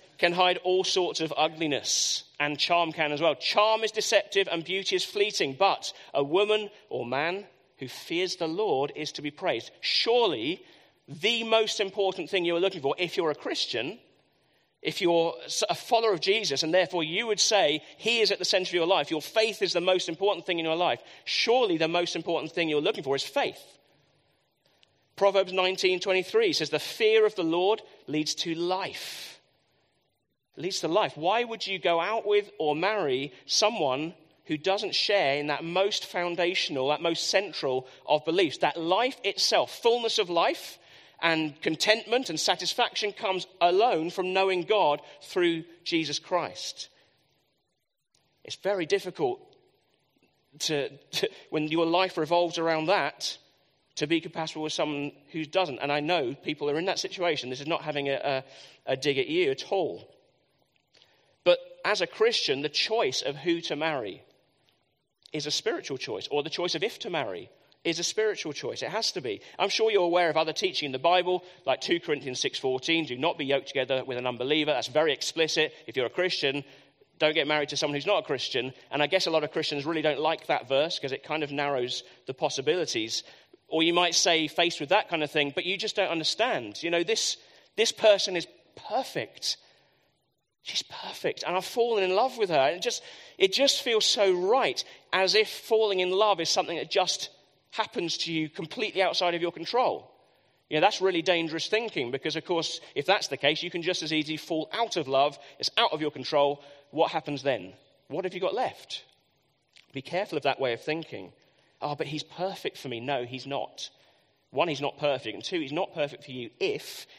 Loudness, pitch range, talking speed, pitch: -27 LUFS, 155-205 Hz, 195 wpm, 175 Hz